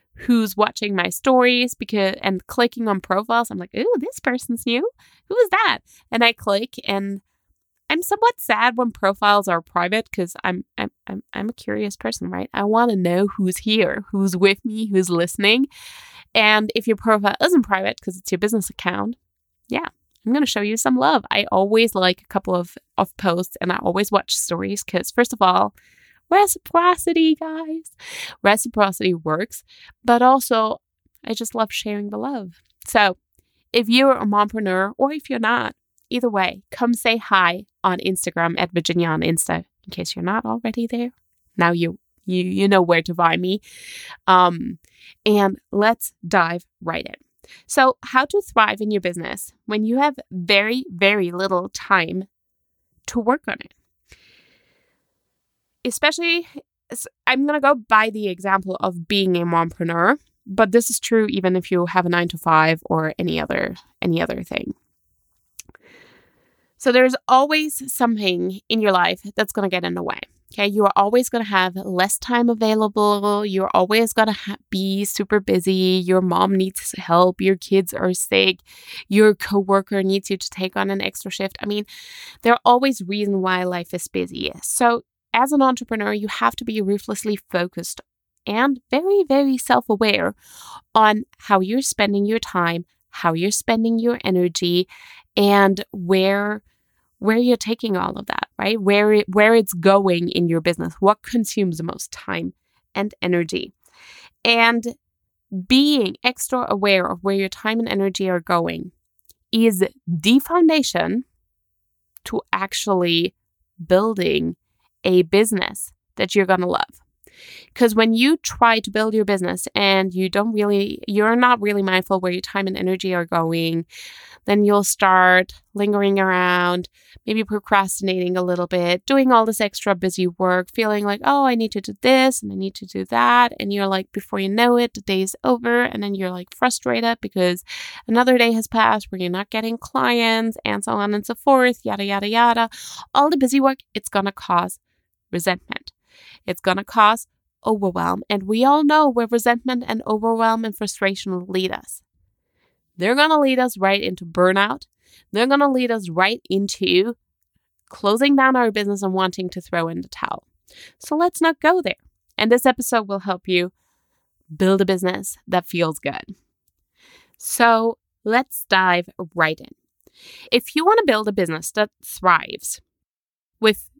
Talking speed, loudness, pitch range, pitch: 170 wpm, -19 LUFS, 185-240 Hz, 205 Hz